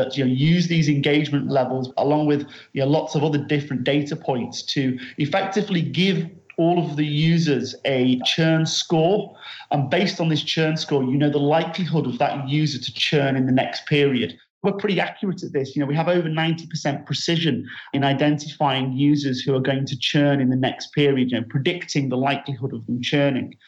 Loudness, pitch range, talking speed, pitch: -21 LUFS, 135-160 Hz, 200 wpm, 145 Hz